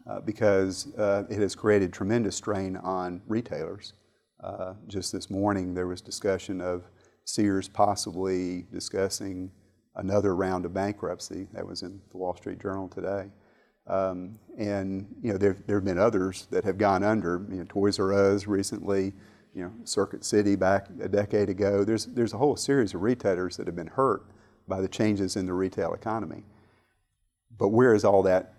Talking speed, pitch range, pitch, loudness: 175 wpm, 95-105 Hz, 100 Hz, -28 LUFS